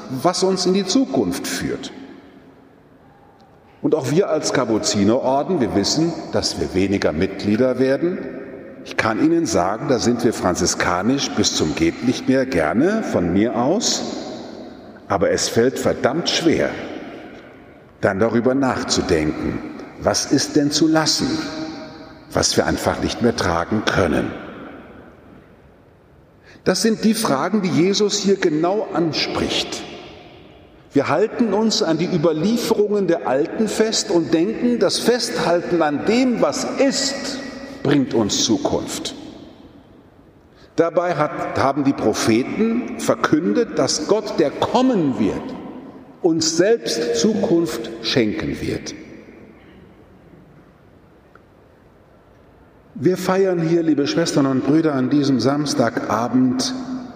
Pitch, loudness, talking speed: 175 Hz, -19 LUFS, 115 wpm